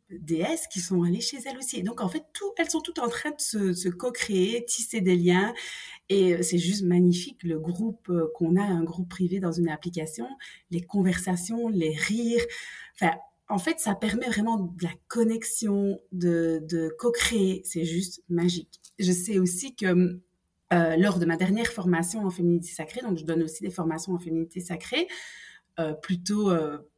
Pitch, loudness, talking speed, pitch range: 180 Hz, -27 LUFS, 180 wpm, 170-220 Hz